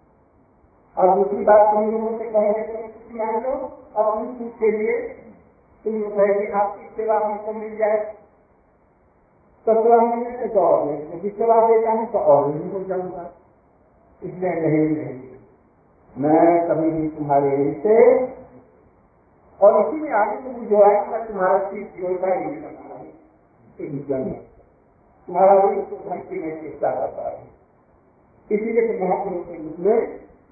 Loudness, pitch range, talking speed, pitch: -20 LUFS, 185-225 Hz, 90 wpm, 210 Hz